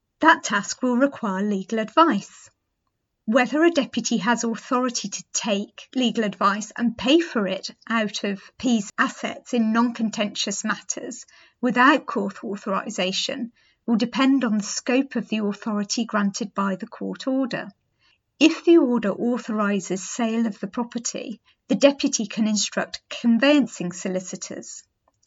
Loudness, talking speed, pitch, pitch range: -23 LUFS, 135 wpm, 230 Hz, 205-255 Hz